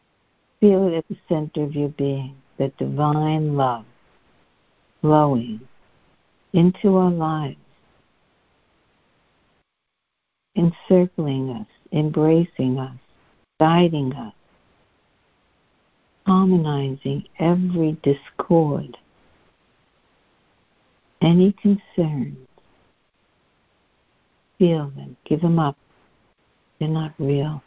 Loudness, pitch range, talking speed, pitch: -21 LUFS, 140-175 Hz, 75 wpm, 155 Hz